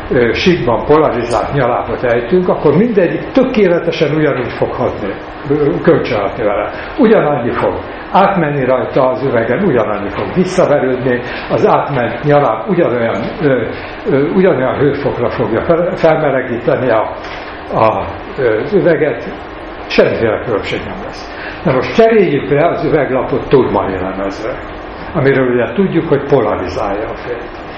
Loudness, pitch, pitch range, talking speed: -13 LUFS, 145 Hz, 125-175 Hz, 110 wpm